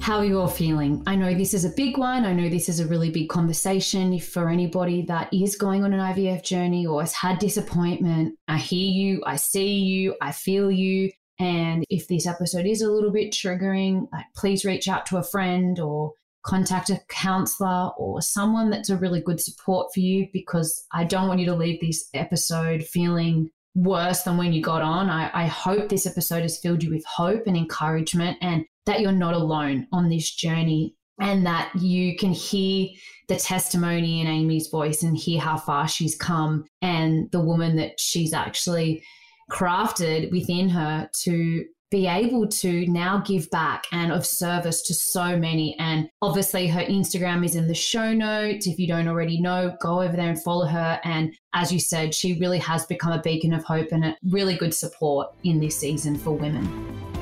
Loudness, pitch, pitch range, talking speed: -24 LUFS, 175 Hz, 165-190 Hz, 195 wpm